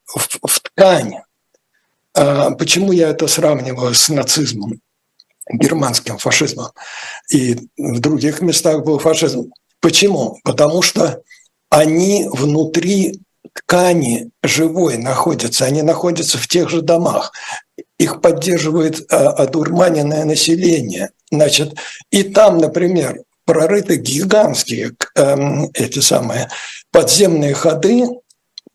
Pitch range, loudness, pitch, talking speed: 145-175 Hz, -14 LUFS, 160 Hz, 95 wpm